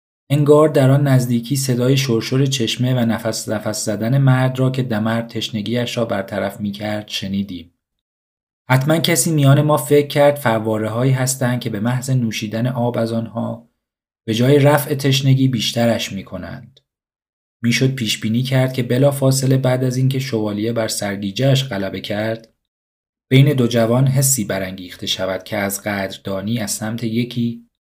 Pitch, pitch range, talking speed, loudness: 115 Hz, 110-130 Hz, 150 wpm, -17 LUFS